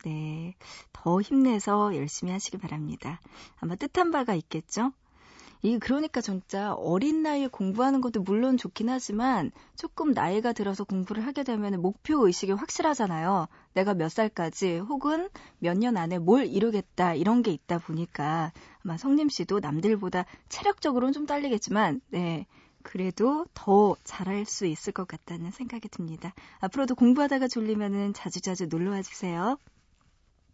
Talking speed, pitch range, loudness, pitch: 325 characters per minute, 180-250 Hz, -28 LUFS, 205 Hz